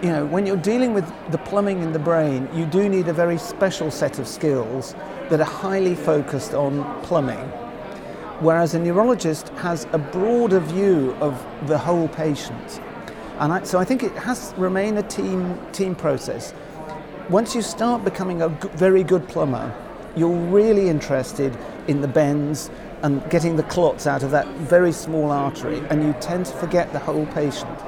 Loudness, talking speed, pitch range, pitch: -21 LUFS, 180 wpm, 150-190 Hz, 165 Hz